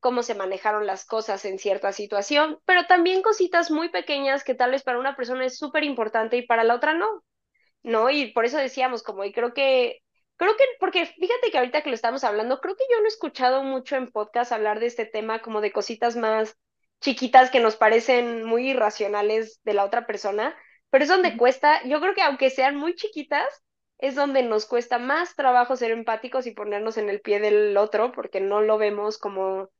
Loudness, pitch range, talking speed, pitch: -23 LUFS, 215-285 Hz, 210 wpm, 245 Hz